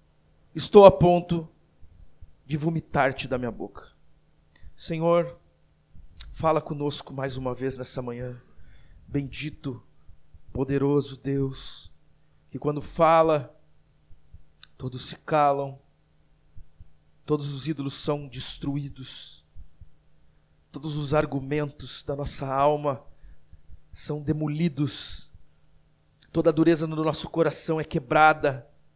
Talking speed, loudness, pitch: 95 wpm, -25 LUFS, 135 Hz